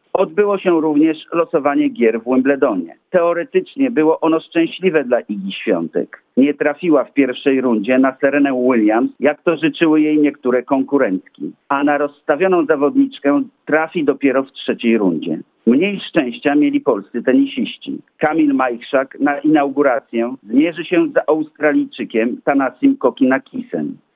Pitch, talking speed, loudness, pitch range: 145 Hz, 130 wpm, -16 LUFS, 135-170 Hz